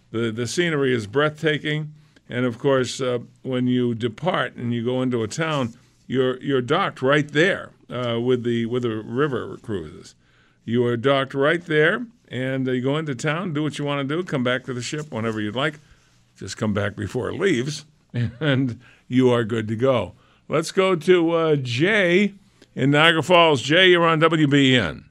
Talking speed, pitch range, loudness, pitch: 190 wpm, 120-155 Hz, -21 LUFS, 135 Hz